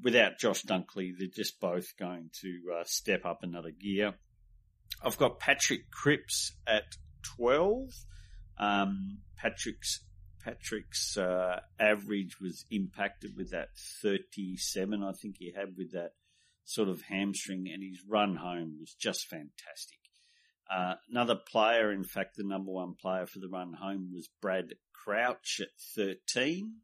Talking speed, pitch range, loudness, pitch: 140 wpm, 90-105 Hz, -34 LUFS, 95 Hz